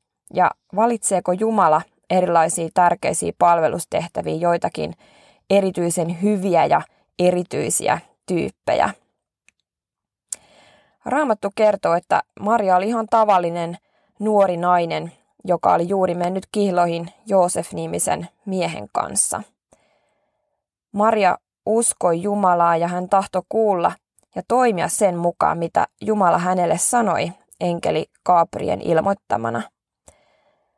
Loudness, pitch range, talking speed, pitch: -20 LUFS, 170-205 Hz, 90 wpm, 180 Hz